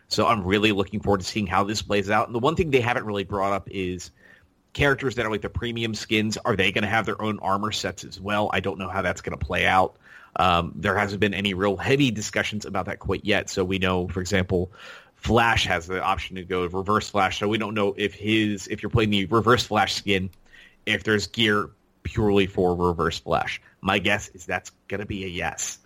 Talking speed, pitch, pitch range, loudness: 235 wpm, 100 Hz, 95-110 Hz, -24 LUFS